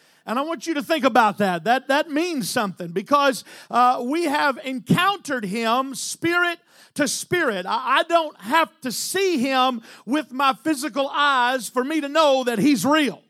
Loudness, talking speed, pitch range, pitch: -21 LUFS, 175 wpm, 245-305 Hz, 270 Hz